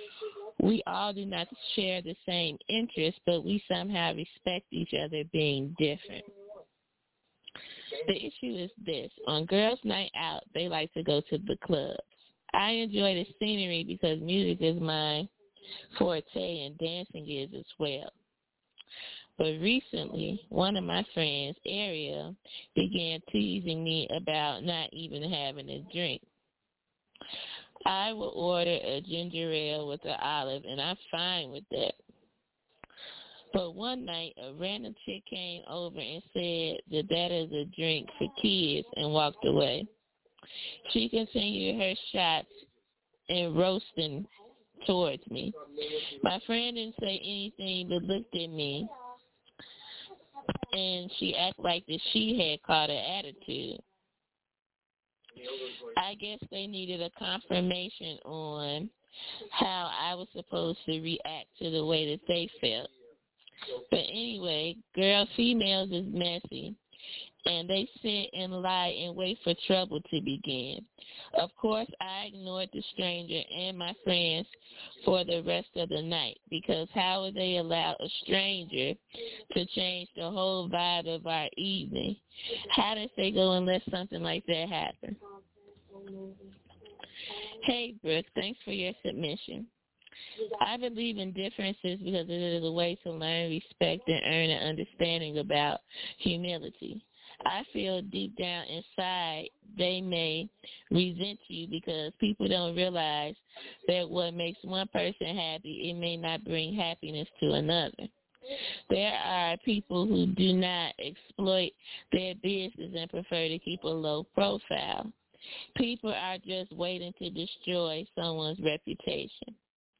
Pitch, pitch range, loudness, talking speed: 180 Hz, 165-205 Hz, -32 LUFS, 135 wpm